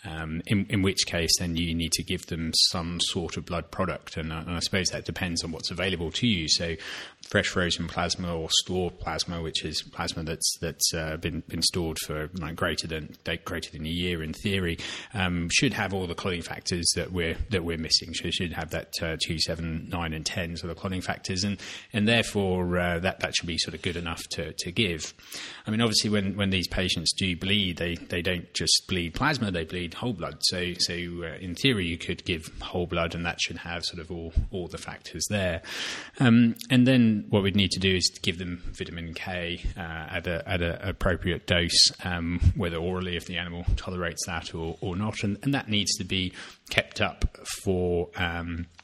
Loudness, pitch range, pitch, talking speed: -27 LUFS, 85-95 Hz, 90 Hz, 215 wpm